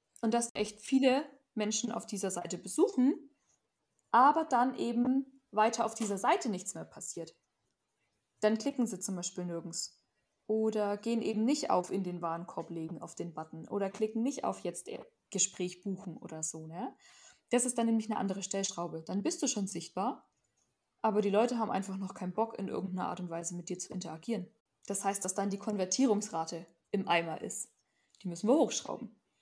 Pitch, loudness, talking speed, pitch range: 205 Hz, -34 LUFS, 180 wpm, 180-235 Hz